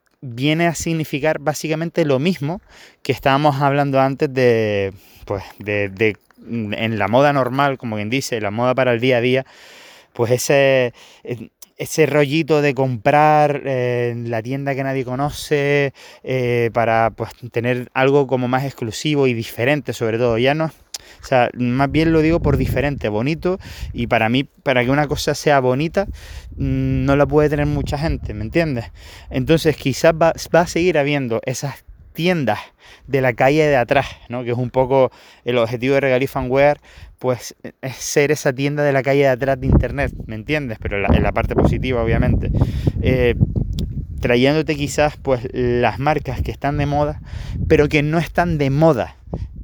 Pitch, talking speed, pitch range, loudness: 130 Hz, 170 wpm, 120-145 Hz, -18 LUFS